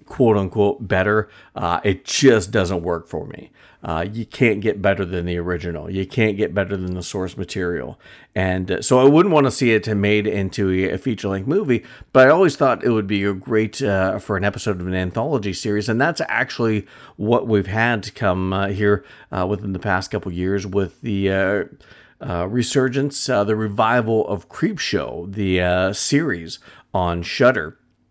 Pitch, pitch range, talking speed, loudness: 100 Hz, 95-110 Hz, 190 wpm, -20 LUFS